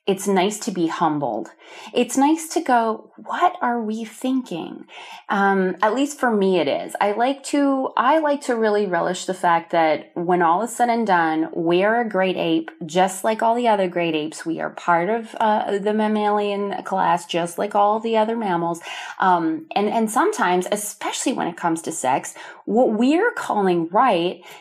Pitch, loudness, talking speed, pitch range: 205 Hz, -21 LUFS, 190 wpm, 175-230 Hz